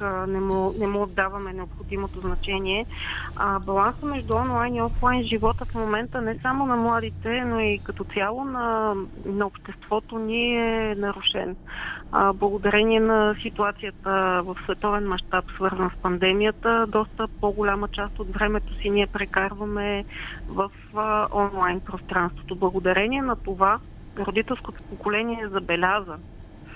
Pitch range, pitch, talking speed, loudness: 190-220 Hz, 205 Hz, 130 wpm, -25 LUFS